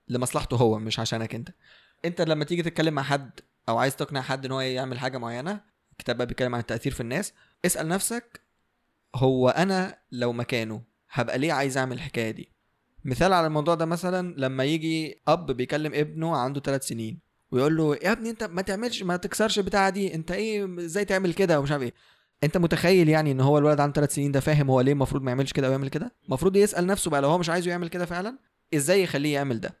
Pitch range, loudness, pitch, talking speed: 130-180 Hz, -26 LUFS, 150 Hz, 215 wpm